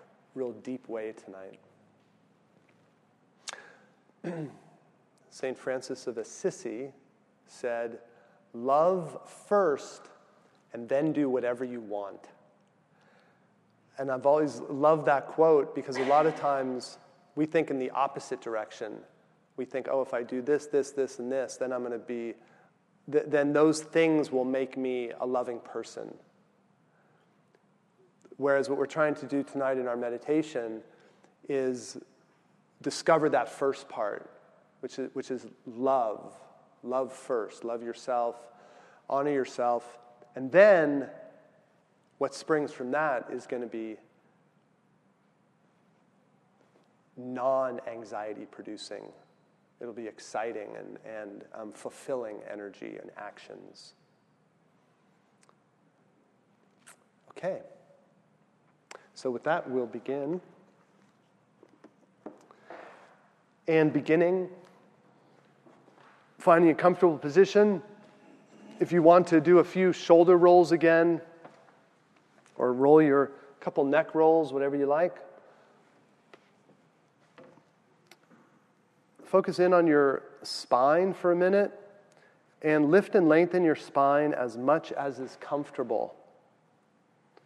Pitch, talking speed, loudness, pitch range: 140 Hz, 110 wpm, -27 LUFS, 125-165 Hz